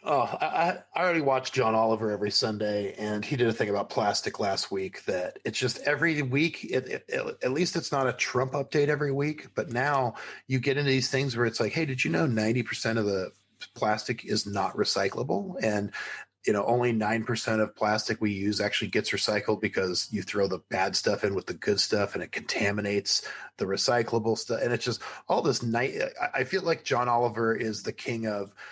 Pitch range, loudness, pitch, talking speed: 105-135 Hz, -28 LUFS, 115 Hz, 205 wpm